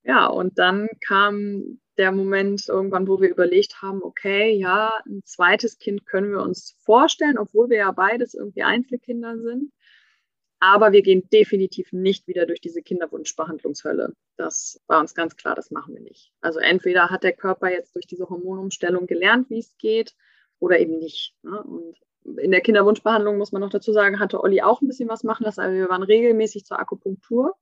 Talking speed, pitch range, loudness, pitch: 185 wpm, 185-225 Hz, -20 LUFS, 200 Hz